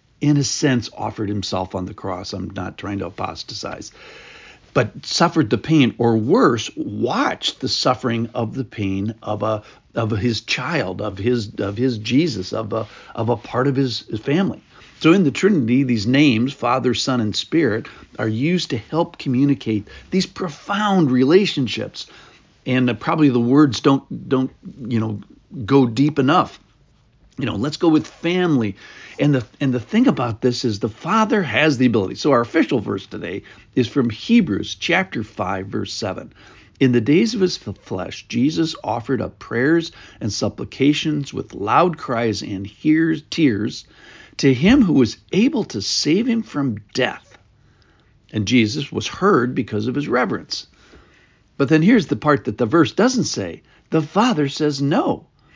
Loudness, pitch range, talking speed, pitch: -19 LUFS, 110-150 Hz, 165 wpm, 130 Hz